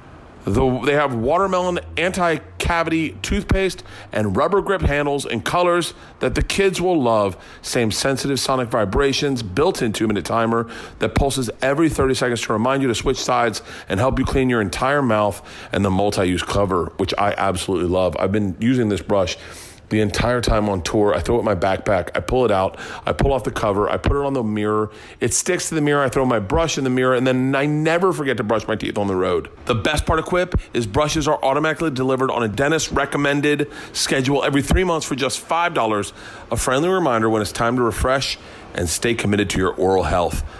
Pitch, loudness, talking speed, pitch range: 130 Hz, -20 LUFS, 215 wpm, 105-145 Hz